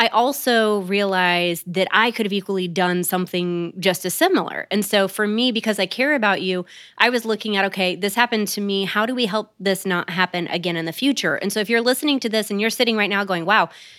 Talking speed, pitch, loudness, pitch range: 240 wpm, 200 Hz, -20 LUFS, 185-225 Hz